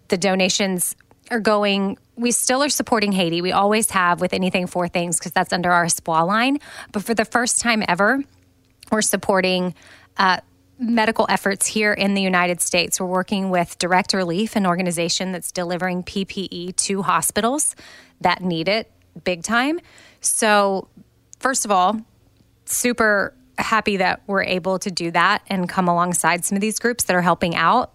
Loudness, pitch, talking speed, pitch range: -20 LUFS, 195 Hz, 165 wpm, 180-220 Hz